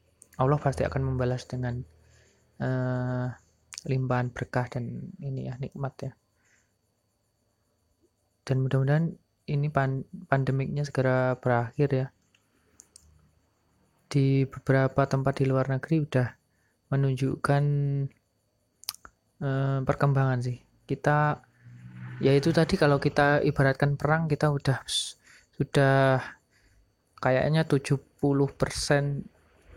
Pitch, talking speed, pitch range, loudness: 130 Hz, 90 wpm, 115-140 Hz, -27 LUFS